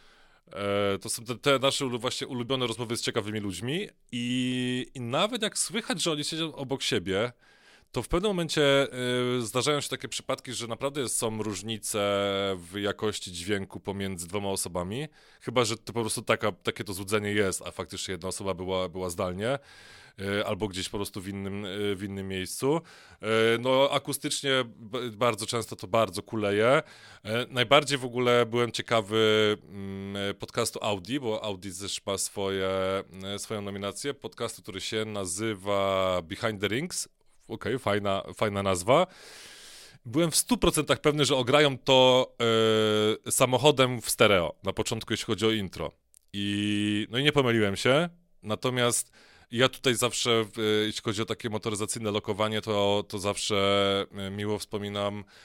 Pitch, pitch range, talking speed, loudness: 110 Hz, 100-125 Hz, 150 wpm, -28 LUFS